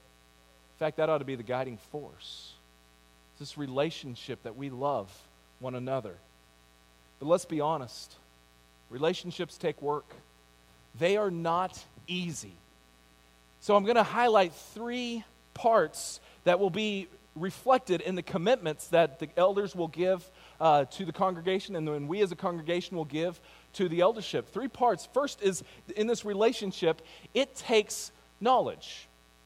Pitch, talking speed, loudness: 155 Hz, 145 wpm, -30 LUFS